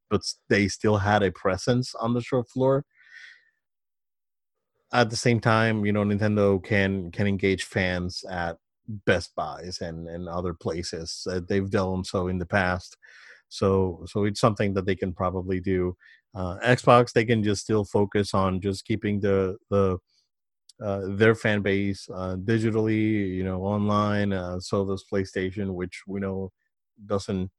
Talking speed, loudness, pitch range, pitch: 160 wpm, -26 LUFS, 95-110 Hz, 100 Hz